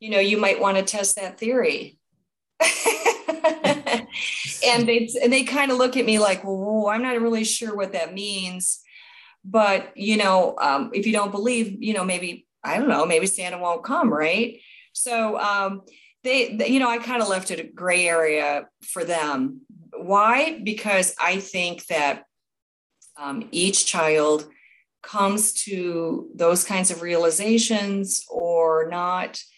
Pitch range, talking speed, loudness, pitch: 185-235 Hz, 160 wpm, -22 LUFS, 205 Hz